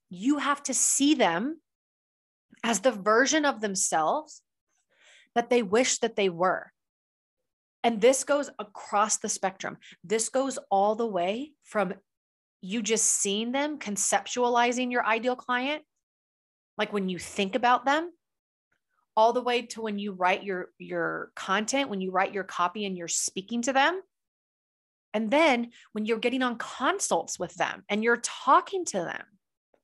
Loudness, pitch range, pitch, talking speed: -27 LUFS, 205-270 Hz, 235 Hz, 155 wpm